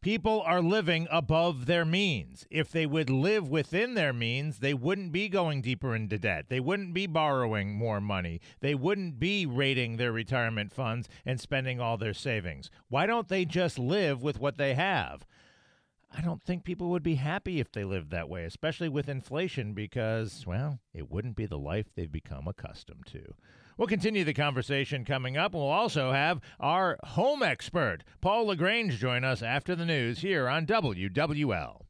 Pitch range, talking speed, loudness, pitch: 115-175 Hz, 180 wpm, -30 LUFS, 140 Hz